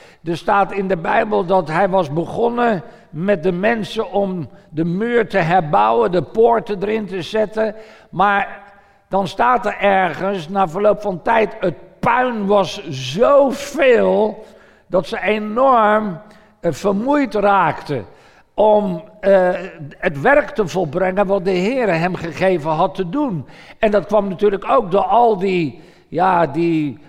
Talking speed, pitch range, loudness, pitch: 140 wpm, 185-220 Hz, -17 LUFS, 200 Hz